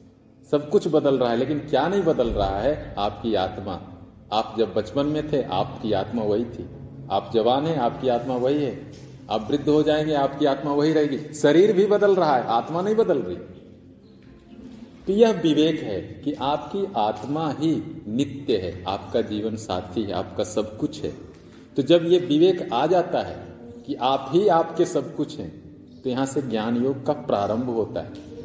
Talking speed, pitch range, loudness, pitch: 190 wpm, 115-155 Hz, -23 LUFS, 140 Hz